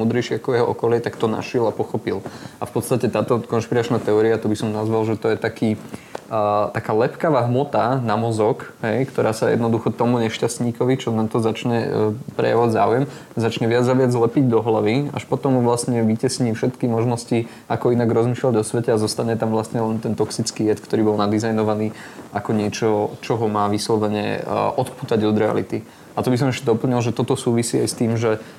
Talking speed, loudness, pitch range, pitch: 195 wpm, -20 LUFS, 110-120 Hz, 115 Hz